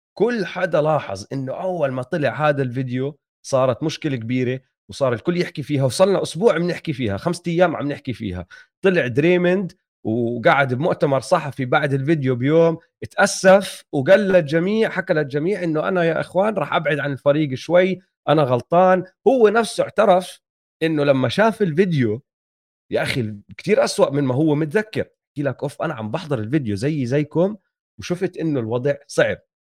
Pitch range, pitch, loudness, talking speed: 135-180 Hz, 155 Hz, -20 LUFS, 155 wpm